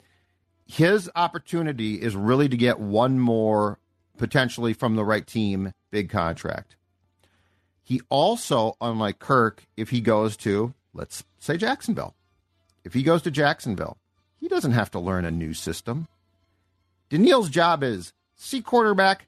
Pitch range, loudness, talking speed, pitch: 90-130 Hz, -24 LUFS, 135 wpm, 110 Hz